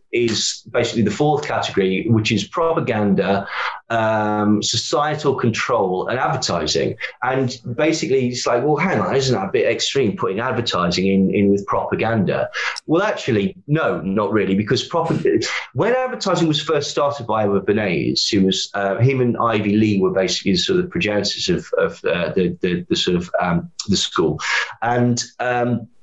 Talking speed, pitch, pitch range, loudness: 165 wpm, 120 Hz, 105-150 Hz, -19 LUFS